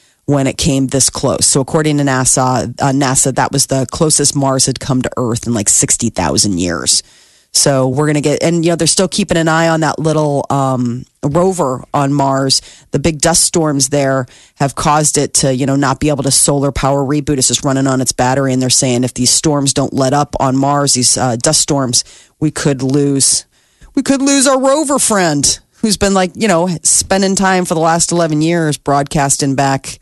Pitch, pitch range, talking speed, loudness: 140 Hz, 130-160 Hz, 210 wpm, -12 LUFS